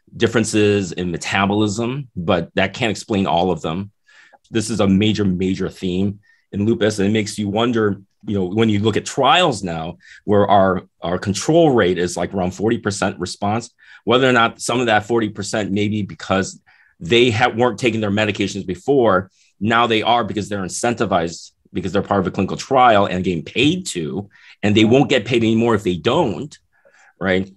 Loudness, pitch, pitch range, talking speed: -18 LUFS, 105 Hz, 95-115 Hz, 185 wpm